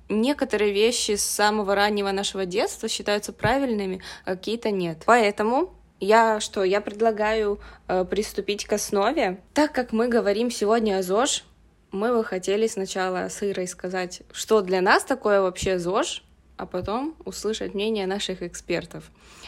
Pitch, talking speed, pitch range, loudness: 205 Hz, 140 wpm, 190-225 Hz, -24 LUFS